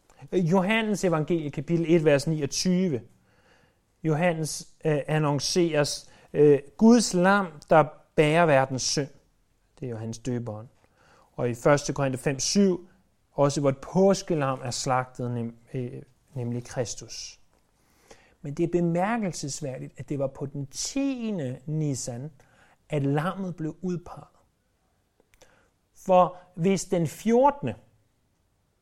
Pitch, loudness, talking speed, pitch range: 150 Hz, -26 LUFS, 115 wpm, 130-175 Hz